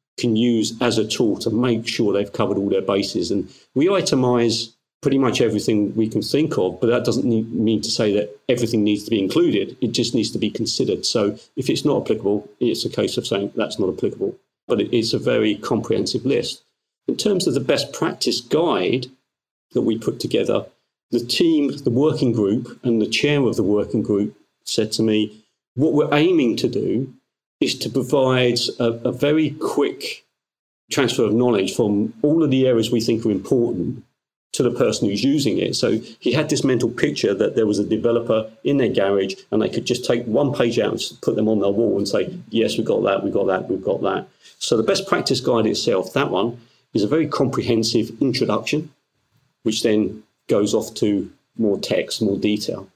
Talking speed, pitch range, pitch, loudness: 205 wpm, 105-130 Hz, 115 Hz, -20 LUFS